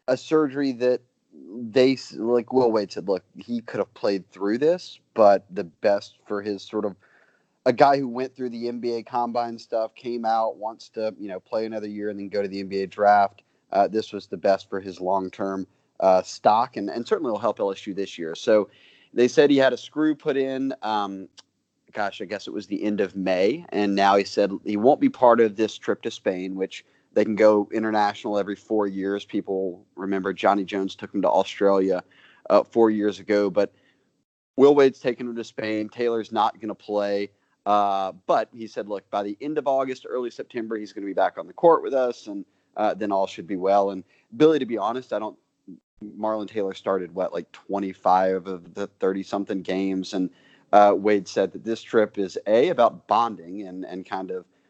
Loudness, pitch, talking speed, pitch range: -24 LUFS, 105 Hz, 210 wpm, 95-120 Hz